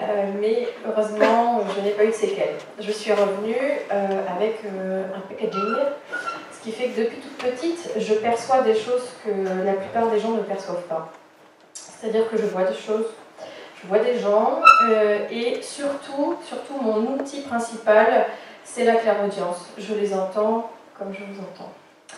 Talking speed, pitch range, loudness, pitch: 170 wpm, 205-250 Hz, -22 LUFS, 220 Hz